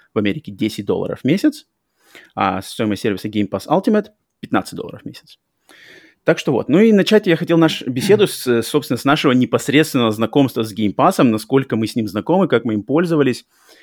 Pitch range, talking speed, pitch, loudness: 115-170 Hz, 190 wpm, 135 Hz, -17 LUFS